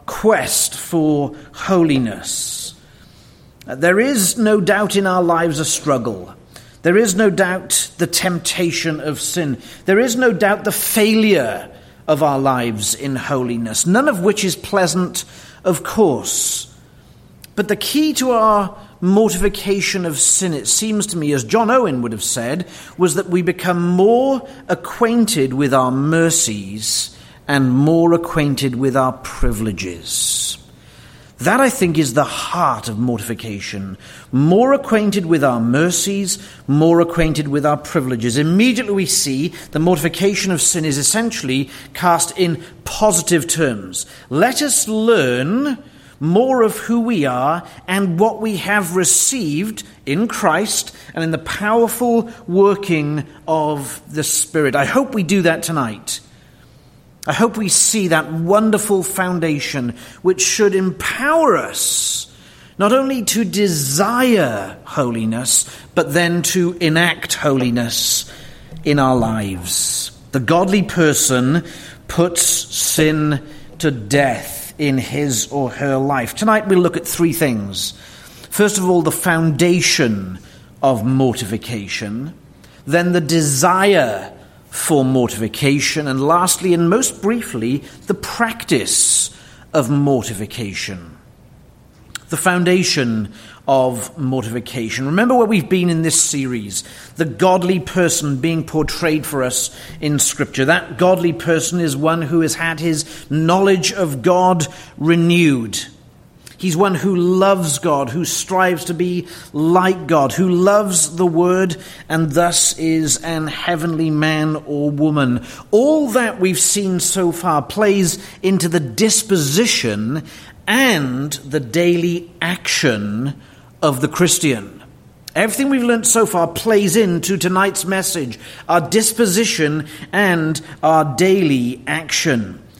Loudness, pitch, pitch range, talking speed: -16 LUFS, 165 Hz, 140-190 Hz, 125 wpm